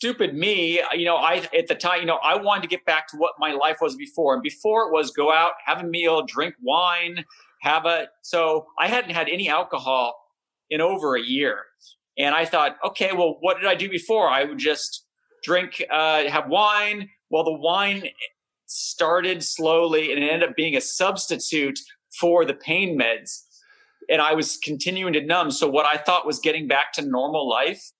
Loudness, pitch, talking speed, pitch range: -22 LUFS, 170 Hz, 200 wpm, 155-205 Hz